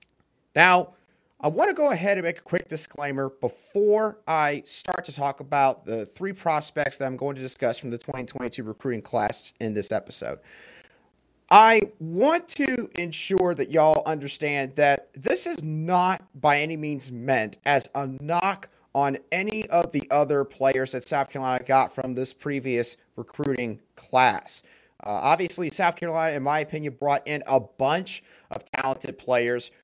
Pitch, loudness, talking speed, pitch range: 145 Hz, -25 LUFS, 160 wpm, 130-170 Hz